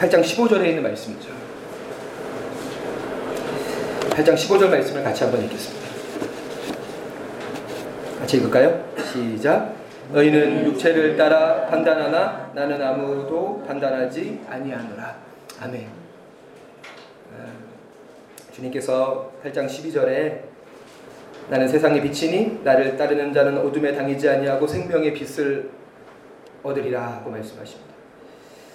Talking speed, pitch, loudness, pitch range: 225 characters per minute, 145 Hz, -21 LUFS, 135-155 Hz